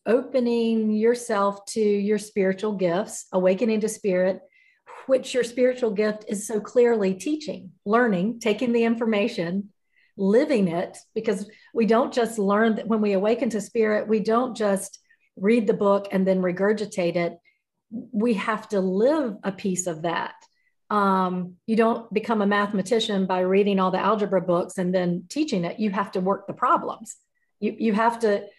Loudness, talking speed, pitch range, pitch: -24 LUFS, 165 wpm, 195-230 Hz, 210 Hz